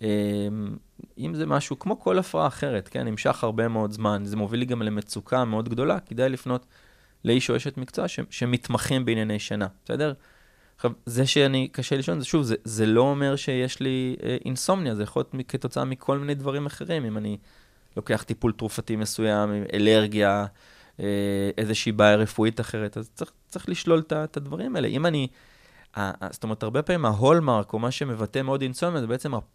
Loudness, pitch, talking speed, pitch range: -26 LUFS, 120 Hz, 180 wpm, 105-135 Hz